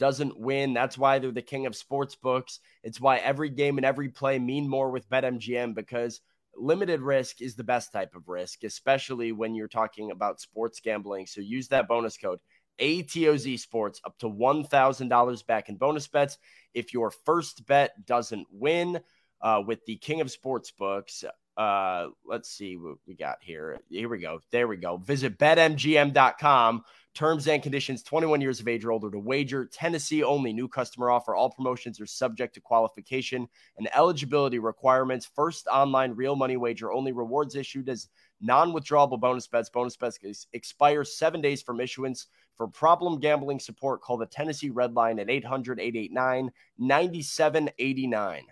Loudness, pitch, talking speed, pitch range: -27 LUFS, 130 Hz, 170 wpm, 120-140 Hz